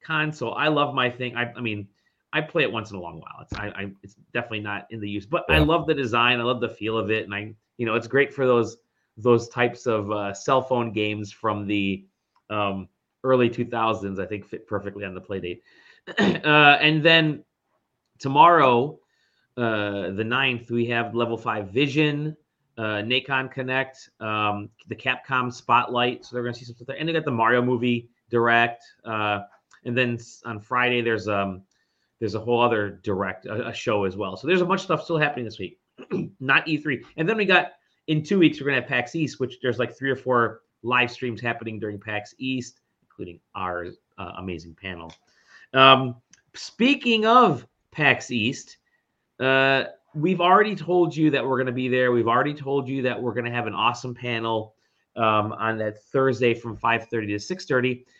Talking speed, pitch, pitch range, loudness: 200 wpm, 120 Hz, 110-135 Hz, -23 LUFS